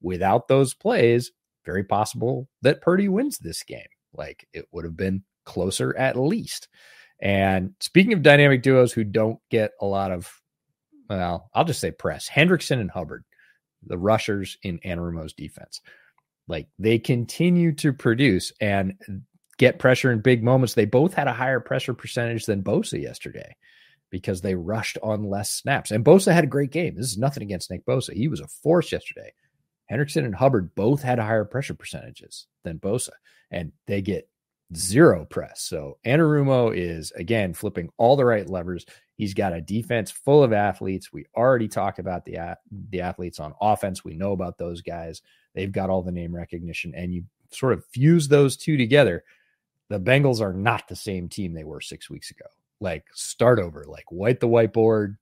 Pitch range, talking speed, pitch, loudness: 95-130 Hz, 180 wpm, 110 Hz, -22 LUFS